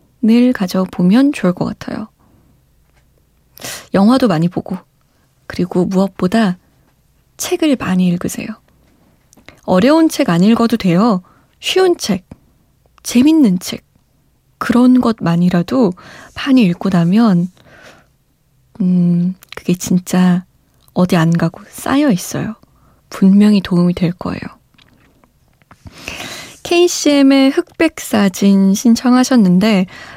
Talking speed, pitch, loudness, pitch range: 205 characters per minute, 195 Hz, -13 LUFS, 180-250 Hz